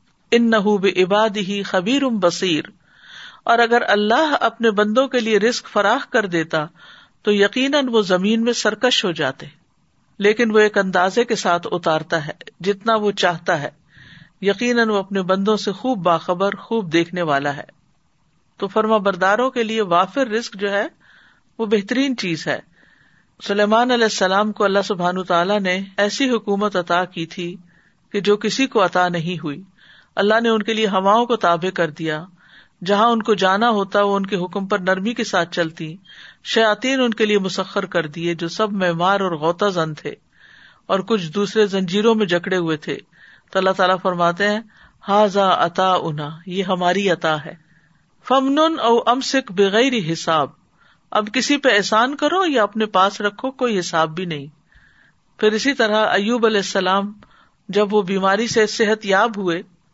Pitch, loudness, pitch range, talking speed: 200 Hz, -18 LUFS, 180-225 Hz, 170 wpm